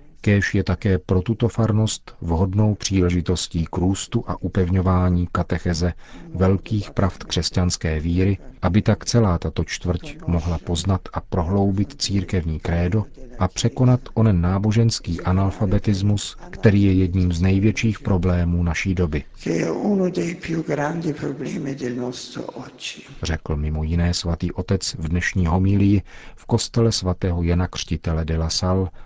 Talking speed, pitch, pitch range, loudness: 120 wpm, 95 Hz, 90-110 Hz, -21 LUFS